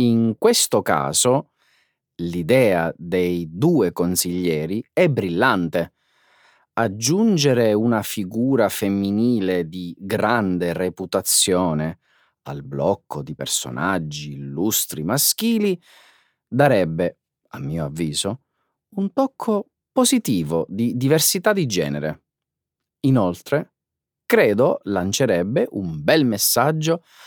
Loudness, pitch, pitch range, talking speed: -20 LUFS, 100 Hz, 85-140 Hz, 85 wpm